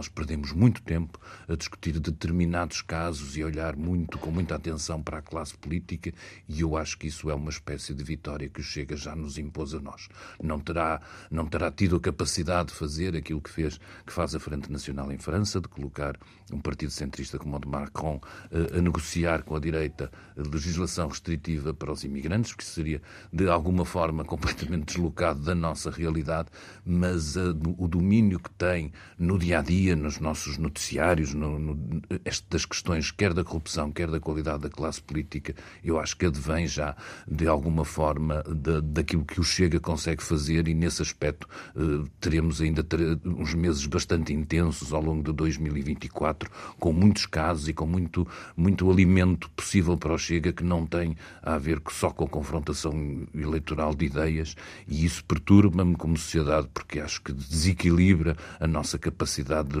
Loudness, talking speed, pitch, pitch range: -28 LUFS, 180 wpm, 80 Hz, 75-85 Hz